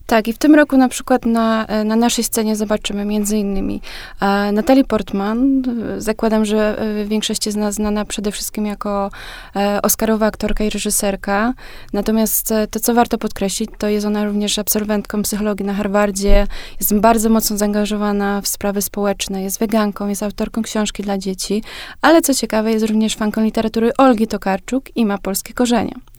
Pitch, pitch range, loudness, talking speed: 215 Hz, 205-225 Hz, -17 LUFS, 160 wpm